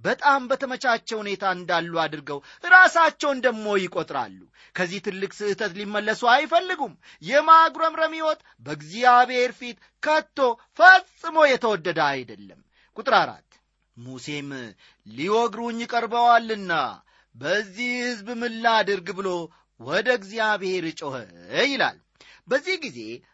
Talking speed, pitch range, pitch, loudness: 95 wpm, 185-260 Hz, 225 Hz, -22 LUFS